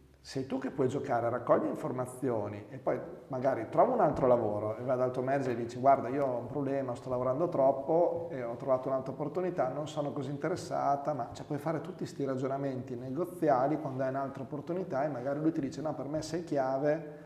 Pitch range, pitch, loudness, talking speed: 130-150 Hz, 135 Hz, -32 LUFS, 210 wpm